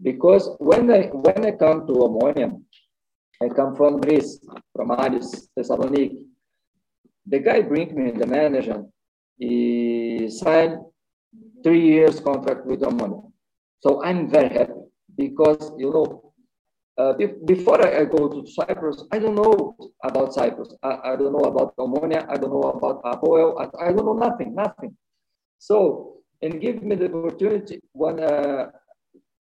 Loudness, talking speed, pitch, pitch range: -21 LUFS, 145 wpm, 155 Hz, 140-205 Hz